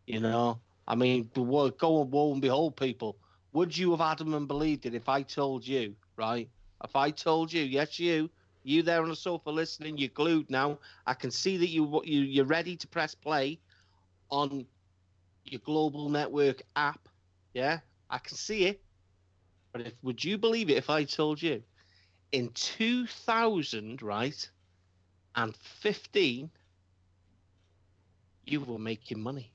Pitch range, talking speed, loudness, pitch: 95-155 Hz, 165 wpm, -31 LUFS, 130 Hz